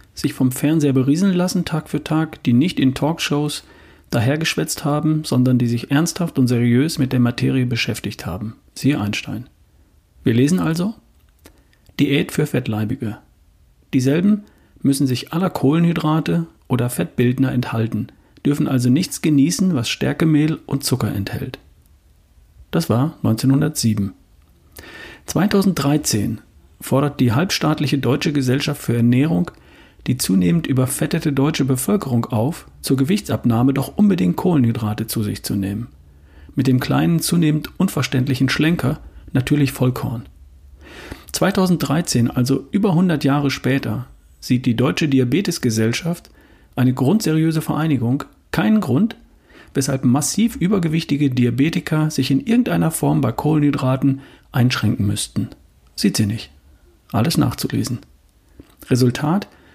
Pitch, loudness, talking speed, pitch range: 135 Hz, -19 LUFS, 120 wpm, 115-155 Hz